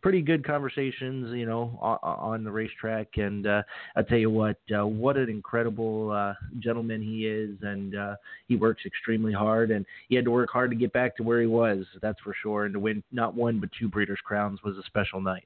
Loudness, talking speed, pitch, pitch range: -28 LUFS, 220 wpm, 110 Hz, 105-120 Hz